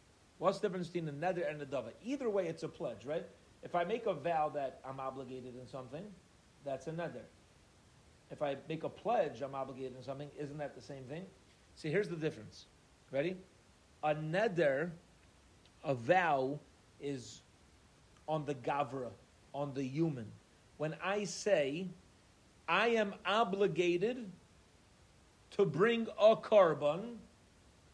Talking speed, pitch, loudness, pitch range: 145 wpm, 150 Hz, -36 LUFS, 130-185 Hz